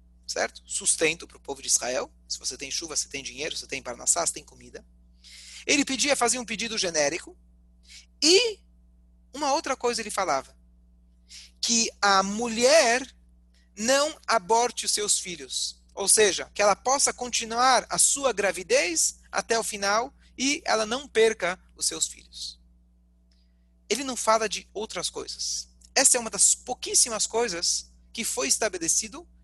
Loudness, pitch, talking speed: -24 LUFS, 195 Hz, 150 wpm